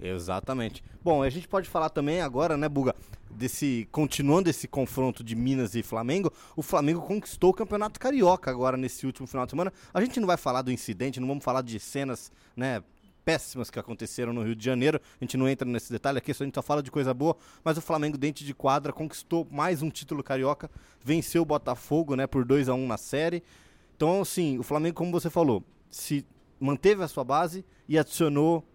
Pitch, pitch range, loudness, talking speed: 140 Hz, 130-165 Hz, -28 LUFS, 210 wpm